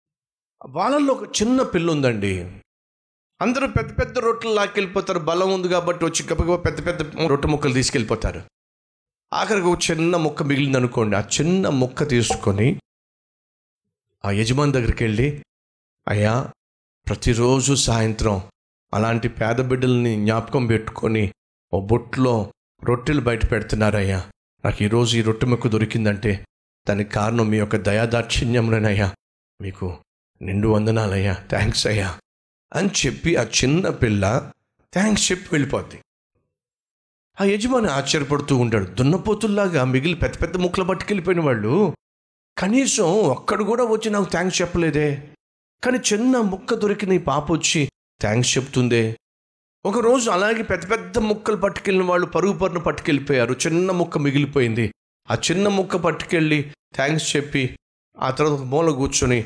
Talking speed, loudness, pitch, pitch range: 115 wpm, -21 LUFS, 140 Hz, 110-180 Hz